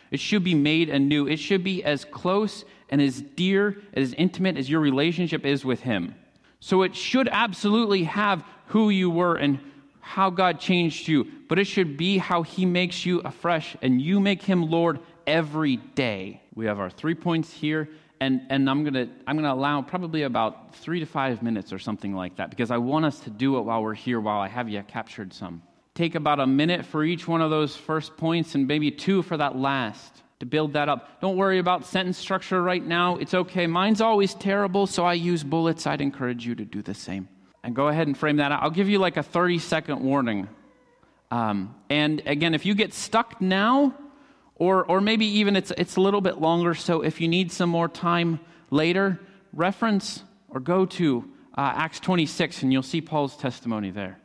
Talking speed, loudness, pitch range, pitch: 210 wpm, -24 LUFS, 140-185 Hz, 165 Hz